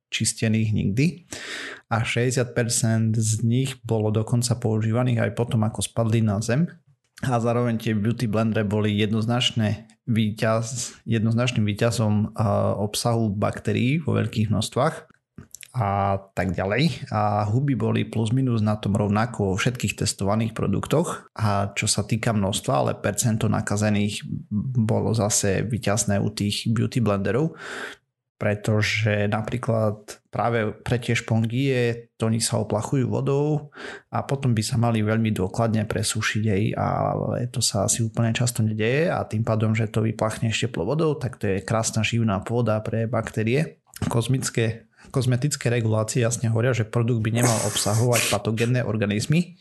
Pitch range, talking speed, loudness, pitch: 105-120 Hz, 140 wpm, -23 LUFS, 115 Hz